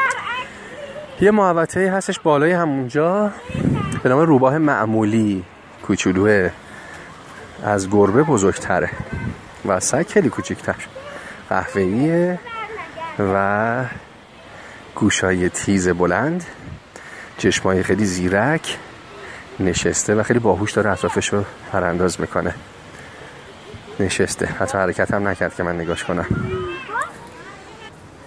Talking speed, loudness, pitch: 90 wpm, -19 LUFS, 110 Hz